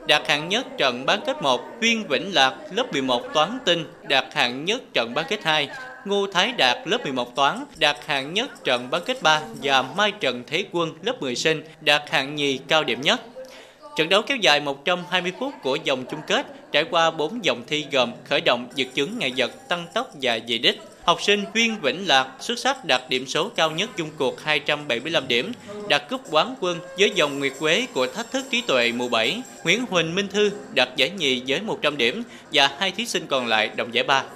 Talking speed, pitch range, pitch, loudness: 220 wpm, 135-205 Hz, 155 Hz, -22 LUFS